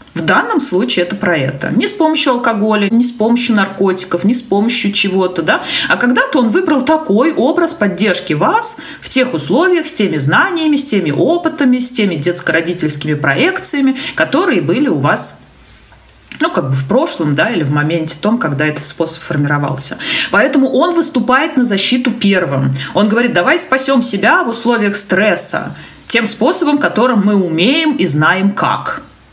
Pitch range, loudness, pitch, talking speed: 175-270 Hz, -12 LUFS, 220 Hz, 165 wpm